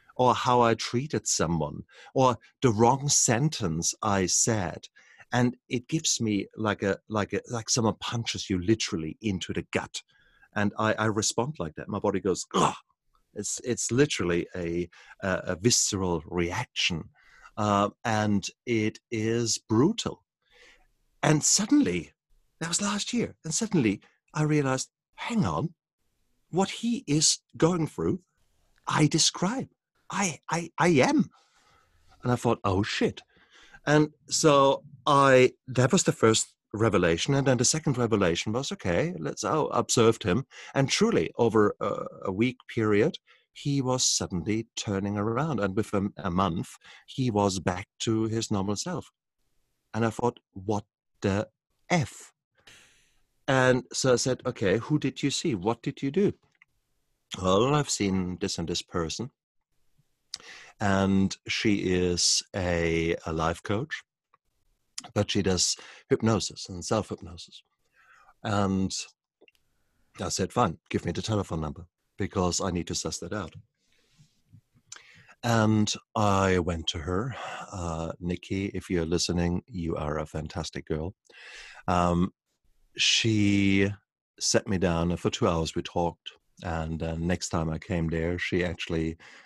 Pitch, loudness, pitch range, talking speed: 105 Hz, -27 LUFS, 90-125 Hz, 140 wpm